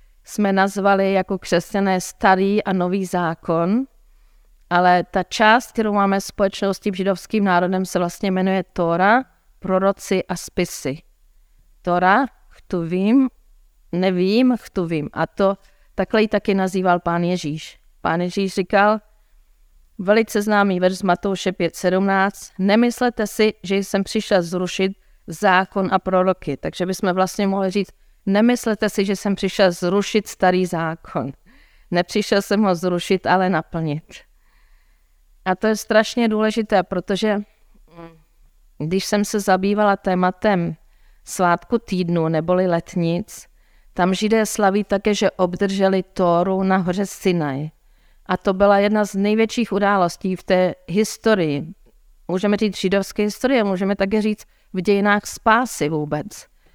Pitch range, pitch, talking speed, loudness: 180-205 Hz, 195 Hz, 125 wpm, -19 LUFS